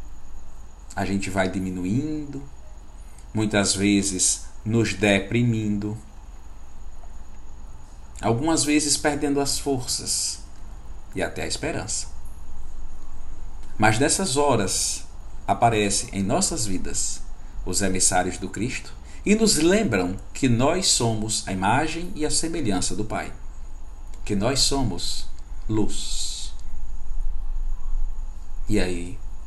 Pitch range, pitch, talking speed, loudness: 65-110 Hz, 90 Hz, 95 wpm, -23 LUFS